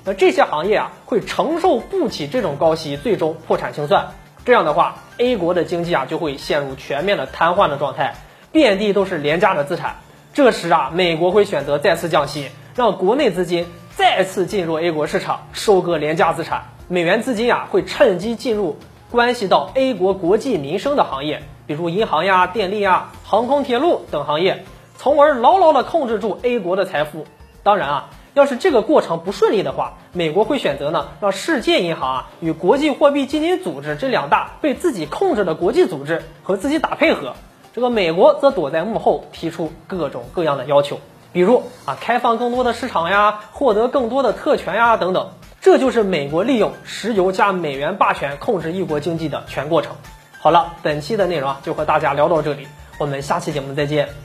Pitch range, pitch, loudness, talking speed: 160-250 Hz, 195 Hz, -18 LUFS, 305 characters per minute